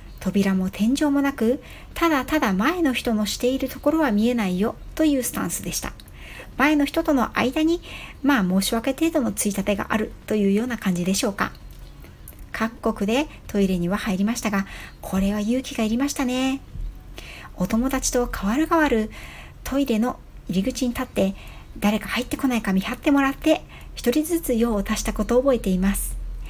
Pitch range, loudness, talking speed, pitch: 200-270 Hz, -23 LUFS, 350 characters per minute, 230 Hz